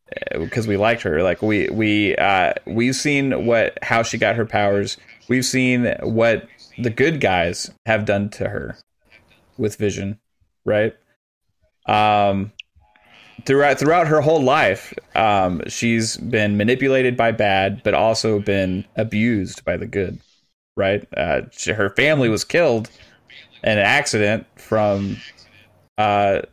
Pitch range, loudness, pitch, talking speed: 100-120 Hz, -19 LUFS, 110 Hz, 135 wpm